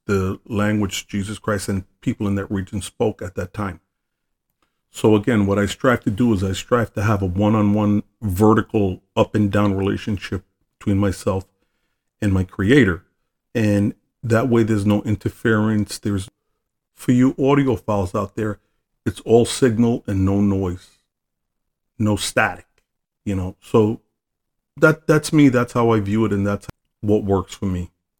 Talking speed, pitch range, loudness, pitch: 160 wpm, 95-110 Hz, -20 LUFS, 105 Hz